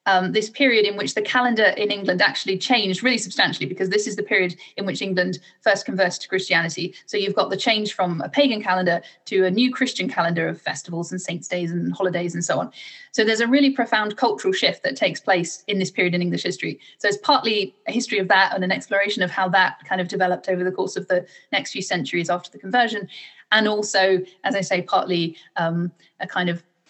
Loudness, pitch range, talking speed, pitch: -21 LUFS, 180-215 Hz, 230 wpm, 190 Hz